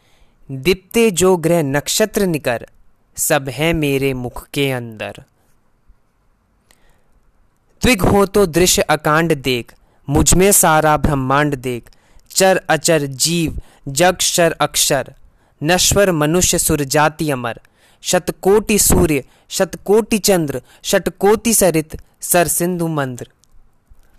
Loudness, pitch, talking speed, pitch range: -15 LUFS, 160 Hz, 100 wpm, 135-185 Hz